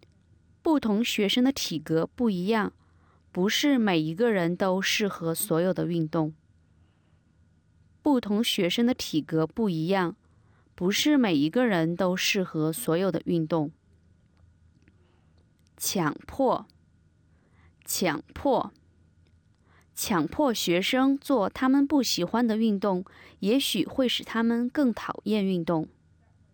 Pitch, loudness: 170 Hz, -26 LUFS